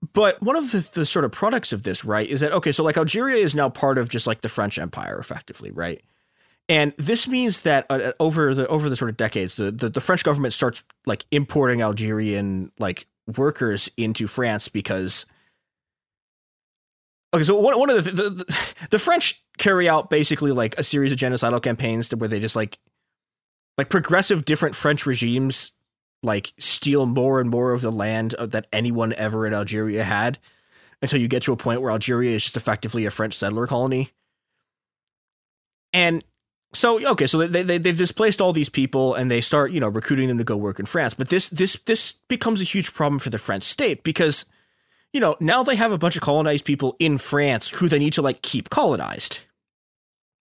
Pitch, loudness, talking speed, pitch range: 135 Hz, -21 LUFS, 200 wpm, 115-160 Hz